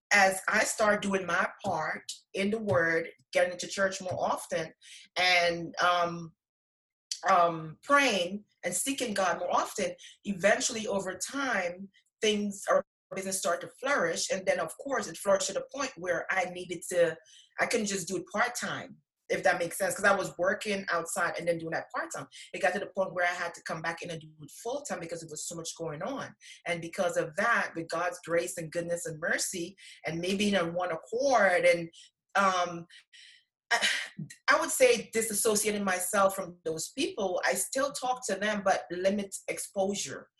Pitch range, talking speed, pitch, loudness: 170-205 Hz, 185 wpm, 185 Hz, -30 LUFS